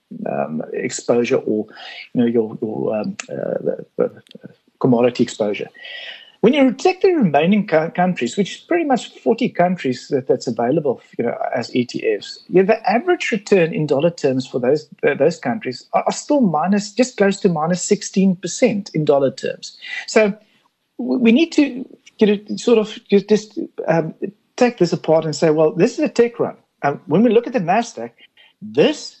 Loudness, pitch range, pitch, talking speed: -18 LUFS, 170-255 Hz, 210 Hz, 180 wpm